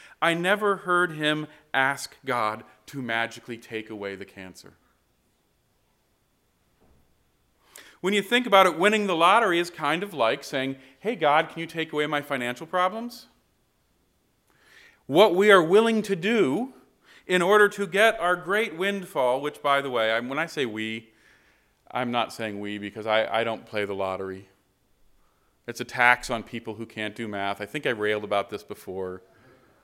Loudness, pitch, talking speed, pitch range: -24 LUFS, 130 Hz, 165 wpm, 110-180 Hz